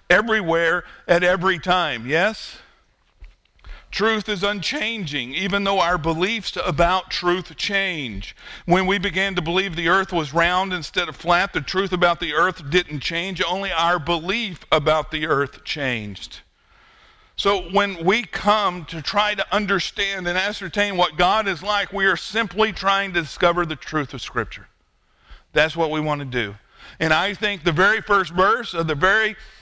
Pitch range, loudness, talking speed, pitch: 165-200 Hz, -21 LUFS, 165 wpm, 180 Hz